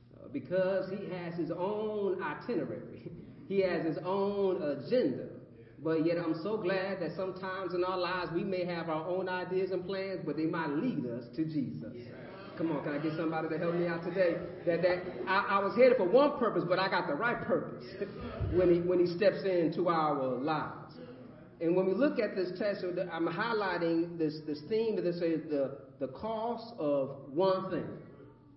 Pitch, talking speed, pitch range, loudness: 180 Hz, 195 wpm, 160-190 Hz, -32 LUFS